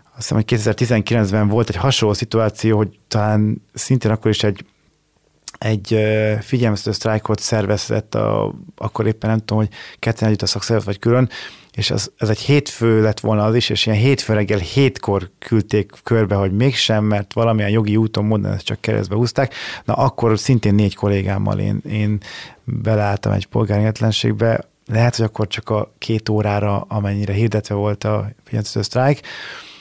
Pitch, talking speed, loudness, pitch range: 110 Hz, 160 wpm, -18 LUFS, 105-115 Hz